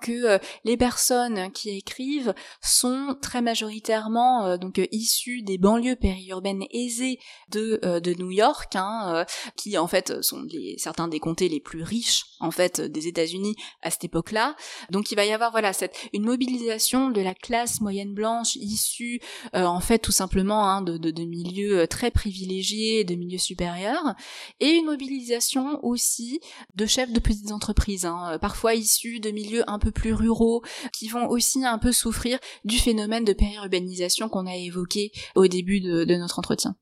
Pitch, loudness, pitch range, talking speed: 215 Hz, -25 LUFS, 190-240 Hz, 175 wpm